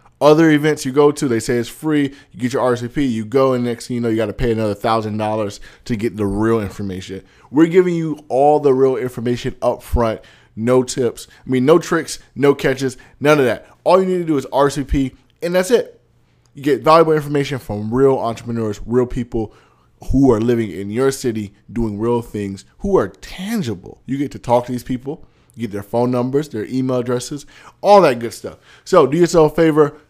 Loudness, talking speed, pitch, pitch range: -17 LUFS, 210 wpm, 125 Hz, 115-145 Hz